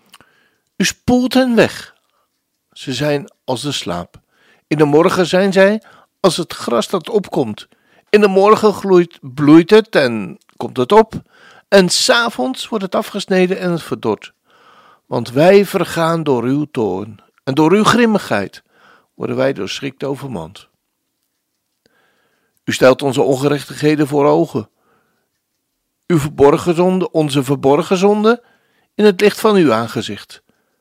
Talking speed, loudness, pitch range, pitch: 135 wpm, -14 LUFS, 140-205 Hz, 170 Hz